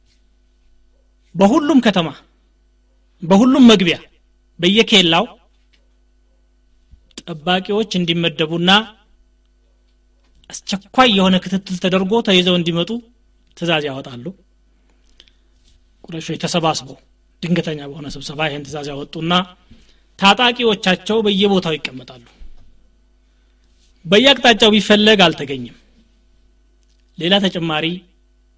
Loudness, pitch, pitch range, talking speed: -15 LUFS, 175 Hz, 145-200 Hz, 65 wpm